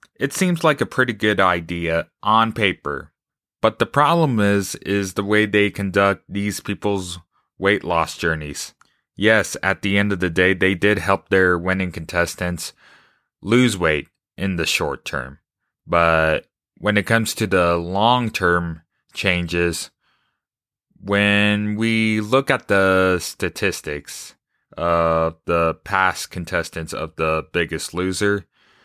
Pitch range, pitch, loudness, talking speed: 85-105 Hz, 95 Hz, -19 LUFS, 135 wpm